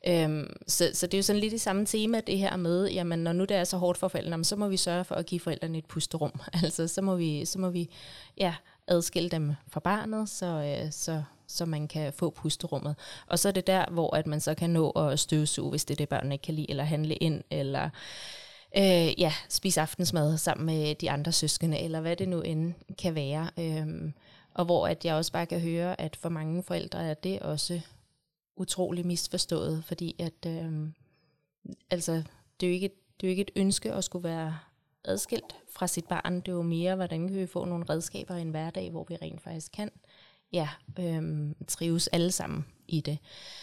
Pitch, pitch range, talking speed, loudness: 170 Hz, 155-180 Hz, 215 wpm, -30 LUFS